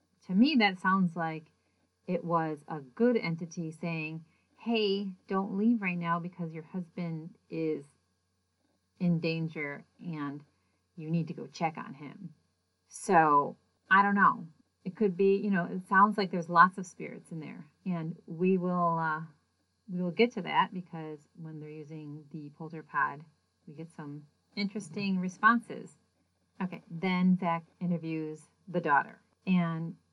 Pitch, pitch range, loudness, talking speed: 170 Hz, 155-190 Hz, -30 LUFS, 150 wpm